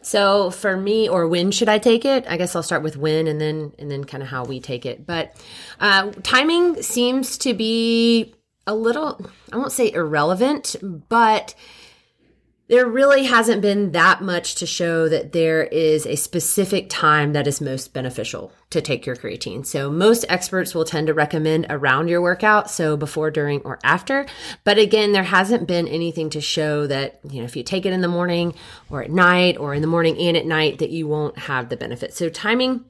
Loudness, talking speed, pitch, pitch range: -19 LUFS, 200 wpm, 175 Hz, 155-215 Hz